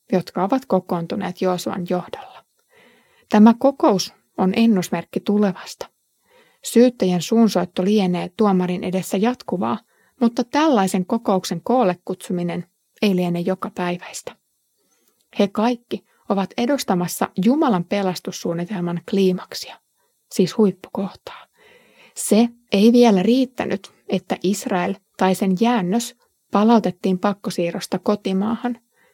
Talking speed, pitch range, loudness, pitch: 95 wpm, 185-235 Hz, -20 LUFS, 200 Hz